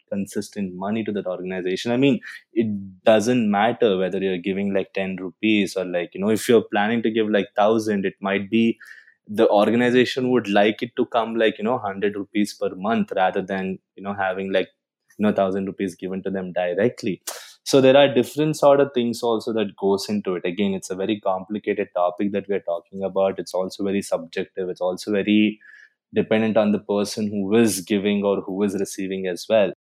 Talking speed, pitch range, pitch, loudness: 200 wpm, 95-110 Hz, 100 Hz, -22 LUFS